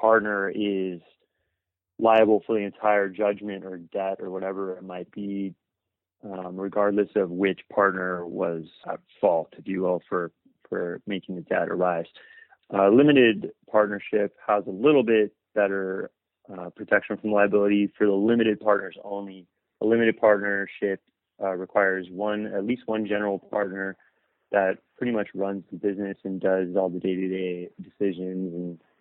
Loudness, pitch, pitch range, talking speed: -25 LUFS, 100 Hz, 95-105 Hz, 150 wpm